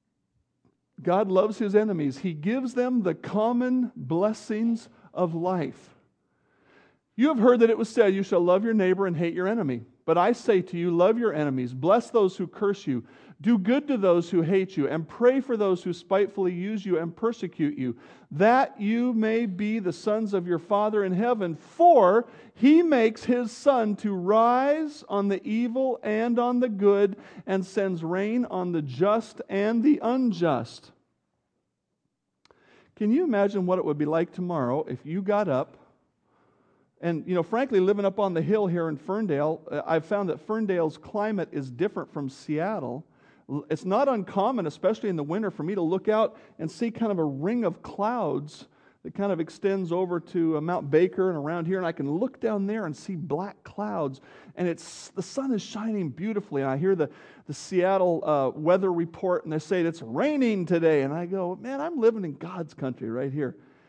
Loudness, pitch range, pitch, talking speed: -26 LUFS, 165-220 Hz, 195 Hz, 190 wpm